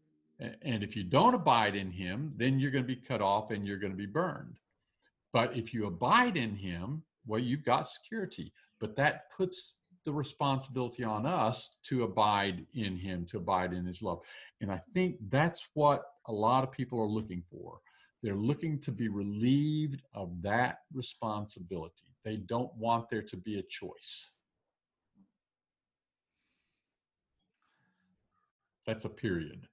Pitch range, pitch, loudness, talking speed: 100-135 Hz, 115 Hz, -33 LUFS, 155 wpm